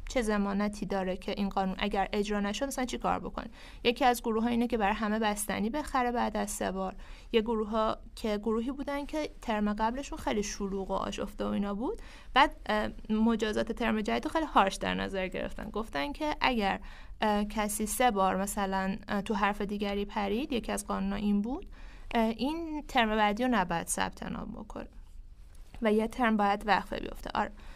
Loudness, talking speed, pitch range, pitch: -31 LUFS, 180 wpm, 200-240 Hz, 215 Hz